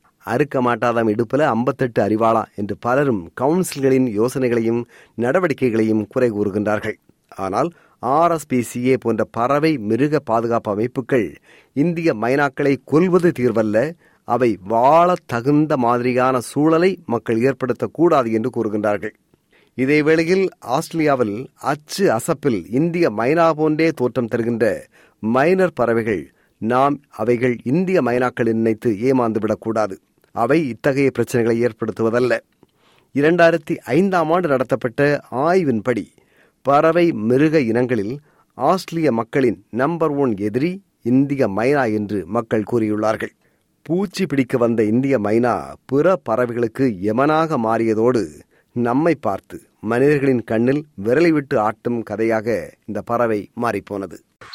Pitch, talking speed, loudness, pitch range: 125 Hz, 100 wpm, -19 LUFS, 115-150 Hz